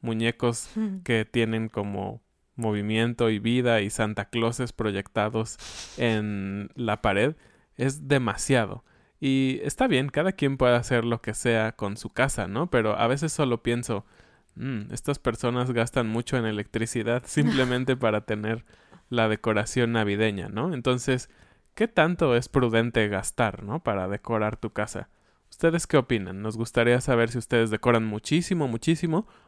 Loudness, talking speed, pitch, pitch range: -26 LUFS, 145 wpm, 115 Hz, 110-125 Hz